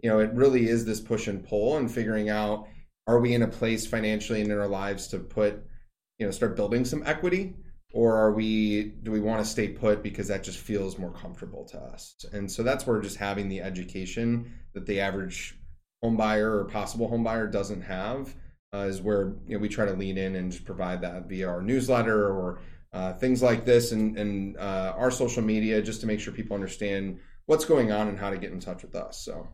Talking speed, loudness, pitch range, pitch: 230 wpm, -28 LUFS, 95-115 Hz, 105 Hz